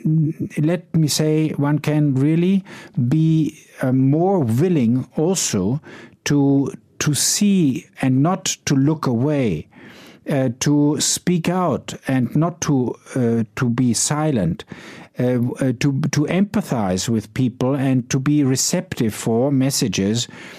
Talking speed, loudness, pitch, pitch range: 120 wpm, -19 LUFS, 145 Hz, 130-155 Hz